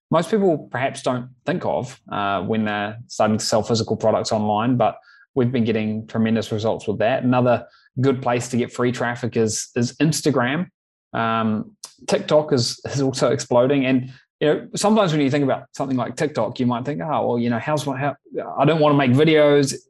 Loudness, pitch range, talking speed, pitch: -21 LUFS, 115-150 Hz, 200 wpm, 130 Hz